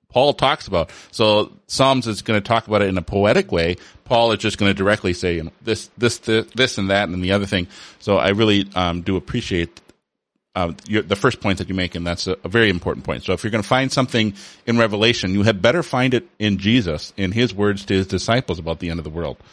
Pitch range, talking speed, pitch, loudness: 95-115 Hz, 260 wpm, 100 Hz, -19 LUFS